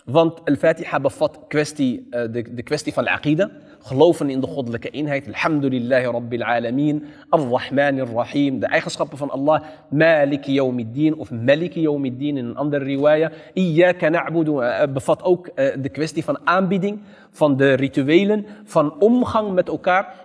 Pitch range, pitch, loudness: 135-165 Hz, 150 Hz, -20 LUFS